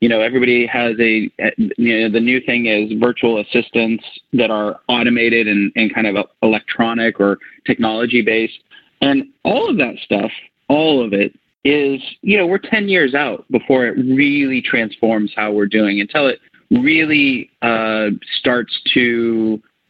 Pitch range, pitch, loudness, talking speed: 110-170 Hz, 115 Hz, -15 LUFS, 155 wpm